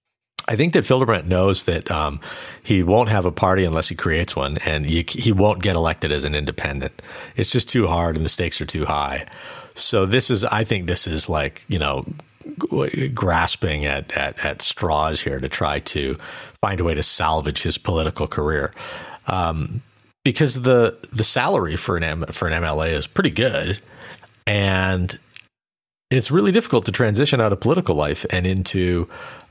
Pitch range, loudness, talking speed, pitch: 80-115 Hz, -19 LUFS, 175 wpm, 95 Hz